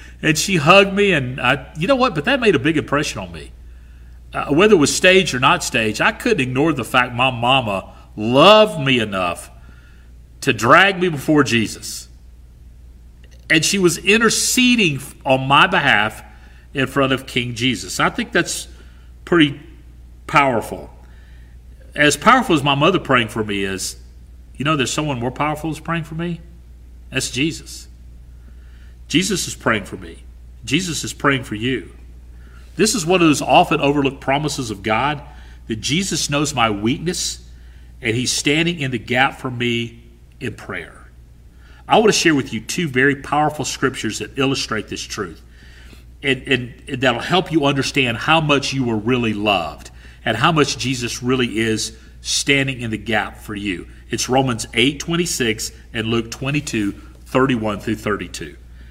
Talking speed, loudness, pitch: 170 wpm, -17 LUFS, 120 Hz